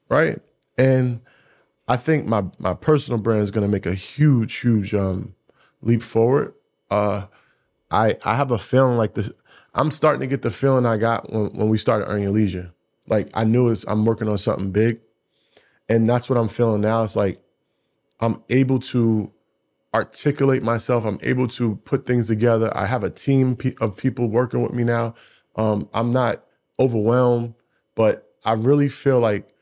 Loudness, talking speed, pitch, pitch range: -21 LUFS, 180 wpm, 115 Hz, 110-125 Hz